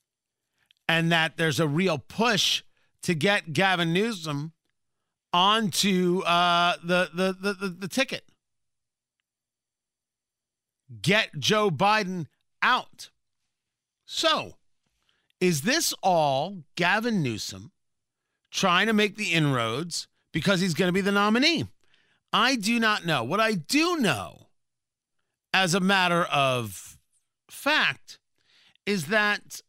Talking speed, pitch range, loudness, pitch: 110 wpm, 155-205 Hz, -24 LUFS, 180 Hz